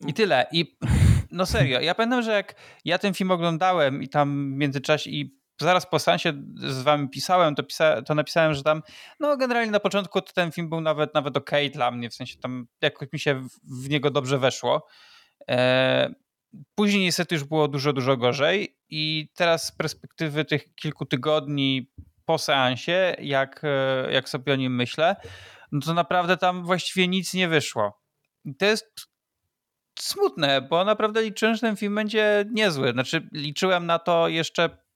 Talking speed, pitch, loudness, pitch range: 175 wpm, 155 Hz, -24 LUFS, 140-180 Hz